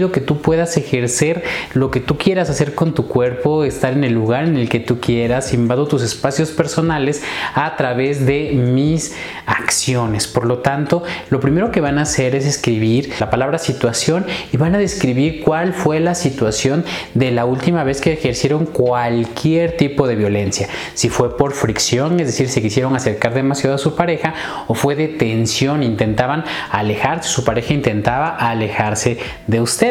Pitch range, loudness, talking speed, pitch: 120-155 Hz, -17 LUFS, 175 wpm, 135 Hz